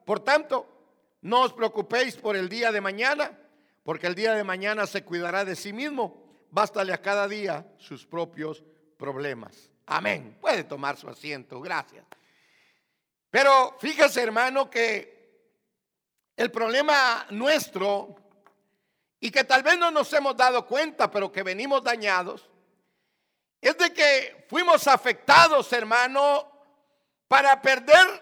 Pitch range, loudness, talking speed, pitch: 200-275 Hz, -23 LUFS, 130 wpm, 240 Hz